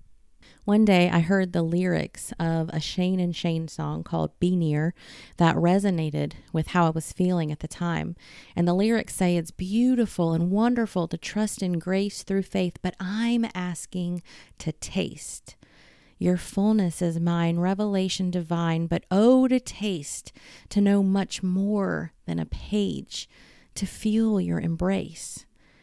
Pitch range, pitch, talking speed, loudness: 170-200 Hz, 180 Hz, 150 wpm, -25 LUFS